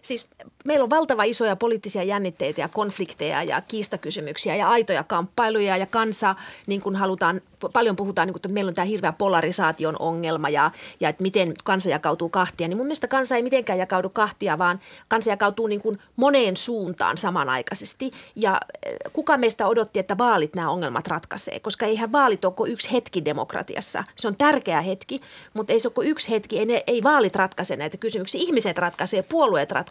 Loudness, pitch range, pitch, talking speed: -23 LUFS, 185-235 Hz, 205 Hz, 175 wpm